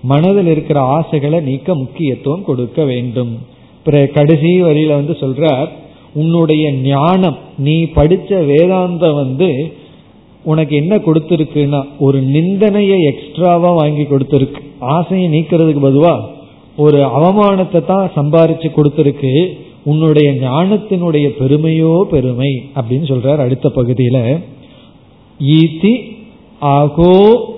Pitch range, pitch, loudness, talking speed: 140-170 Hz, 155 Hz, -12 LUFS, 95 wpm